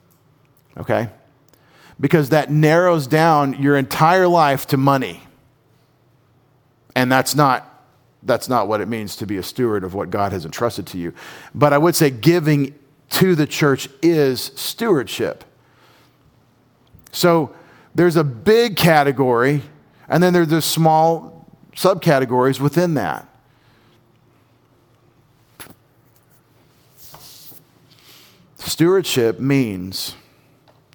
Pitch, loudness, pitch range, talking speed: 140 Hz, -17 LUFS, 125-160 Hz, 105 wpm